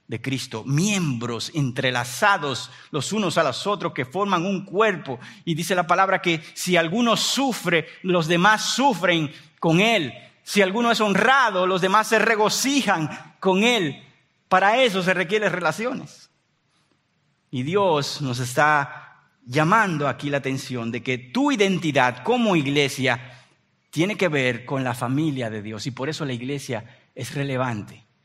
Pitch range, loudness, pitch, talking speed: 135-200 Hz, -22 LUFS, 165 Hz, 150 wpm